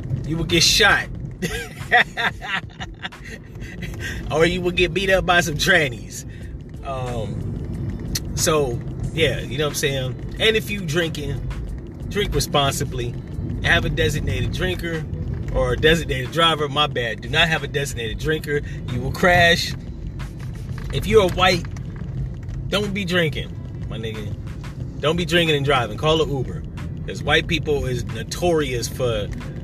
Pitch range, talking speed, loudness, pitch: 125-160 Hz, 140 wpm, -21 LUFS, 140 Hz